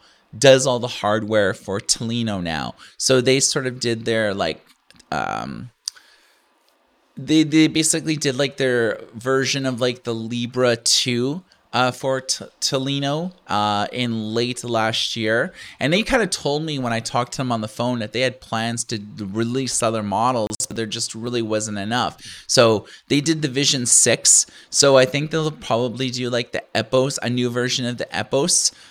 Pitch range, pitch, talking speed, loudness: 115-135 Hz, 125 Hz, 175 wpm, -20 LUFS